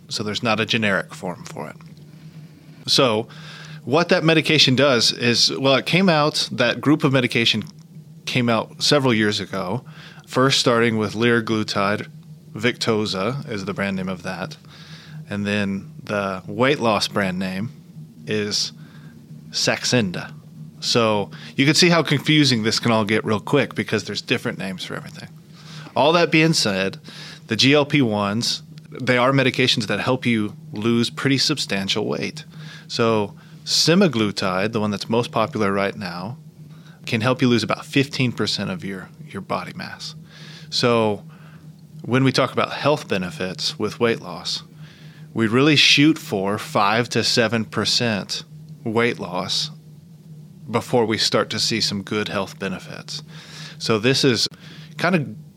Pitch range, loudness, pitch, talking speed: 110-160 Hz, -20 LUFS, 140 Hz, 145 wpm